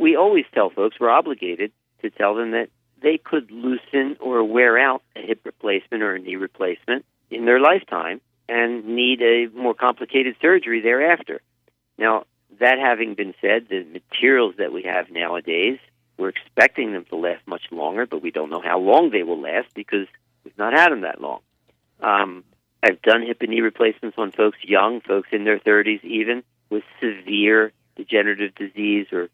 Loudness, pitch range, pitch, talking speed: -20 LUFS, 105-125 Hz, 115 Hz, 180 wpm